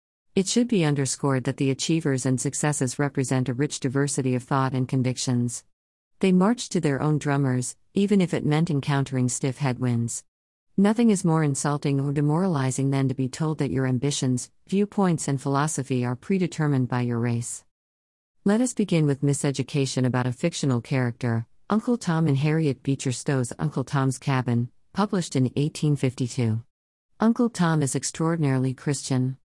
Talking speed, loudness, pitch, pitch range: 155 wpm, -25 LUFS, 140 Hz, 125-155 Hz